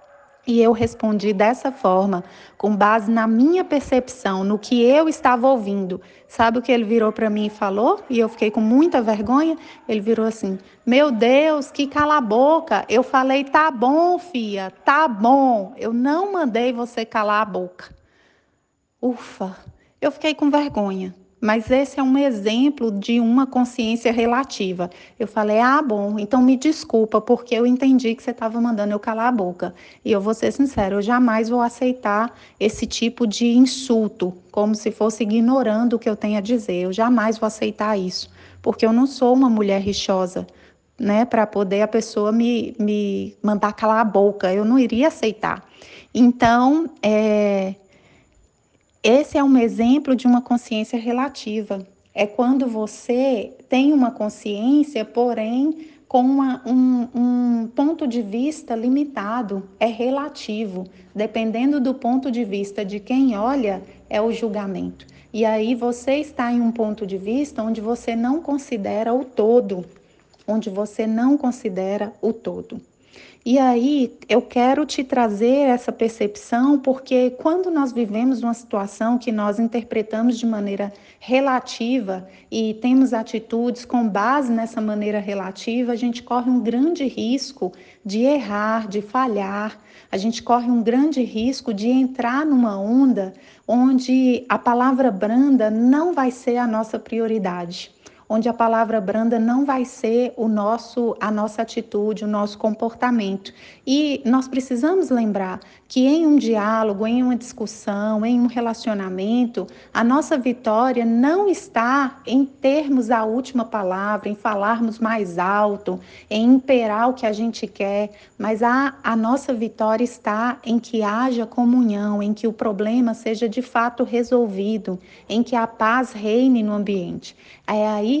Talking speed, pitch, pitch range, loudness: 155 wpm, 230 Hz, 215-255 Hz, -20 LUFS